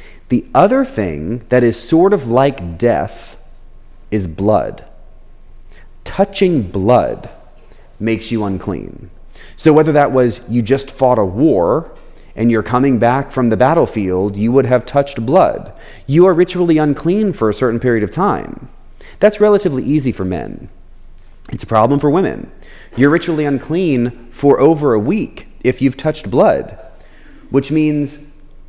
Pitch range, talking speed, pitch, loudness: 110-150 Hz, 145 wpm, 125 Hz, -14 LUFS